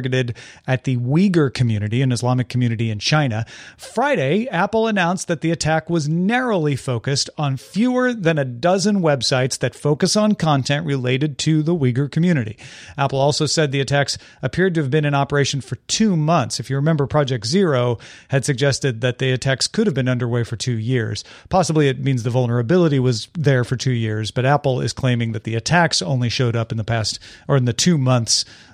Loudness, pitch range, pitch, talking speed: -19 LUFS, 125-160 Hz, 135 Hz, 190 wpm